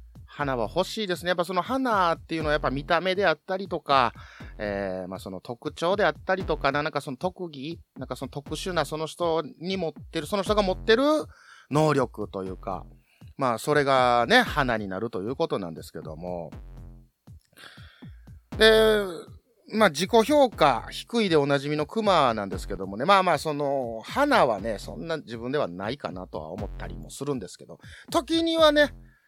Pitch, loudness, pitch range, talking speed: 155 Hz, -25 LUFS, 125-195 Hz, 350 characters per minute